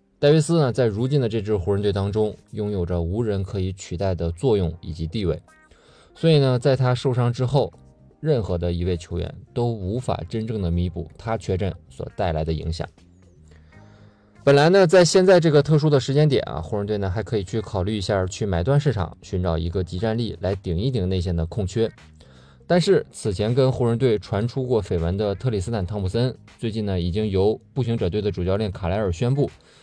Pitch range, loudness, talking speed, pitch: 90-125 Hz, -22 LUFS, 305 characters per minute, 105 Hz